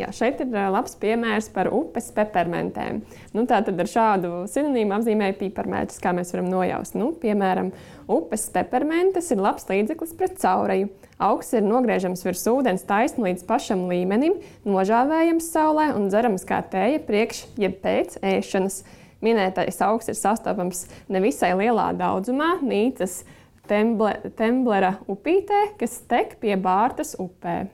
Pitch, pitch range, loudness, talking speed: 215 Hz, 190-250 Hz, -23 LUFS, 130 wpm